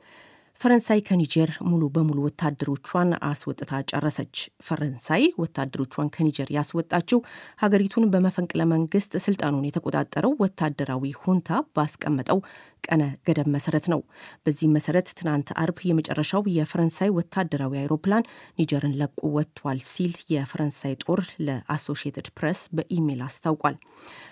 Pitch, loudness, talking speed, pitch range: 155 Hz, -25 LUFS, 100 wpm, 145-175 Hz